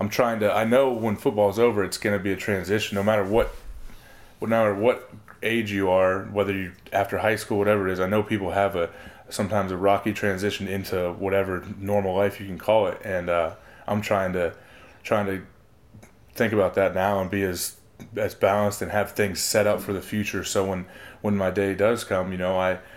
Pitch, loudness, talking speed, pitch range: 100 Hz, -24 LUFS, 215 wpm, 95-105 Hz